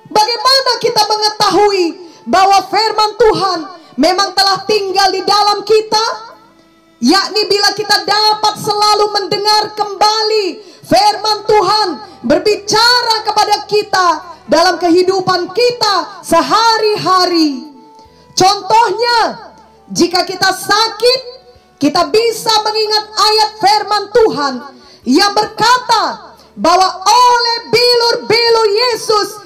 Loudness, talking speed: -11 LUFS, 90 wpm